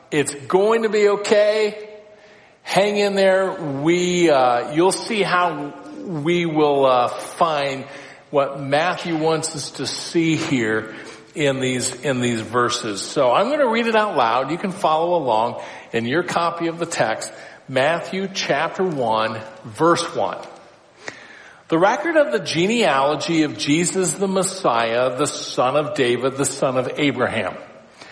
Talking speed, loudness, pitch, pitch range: 145 wpm, -19 LUFS, 155 Hz, 135-185 Hz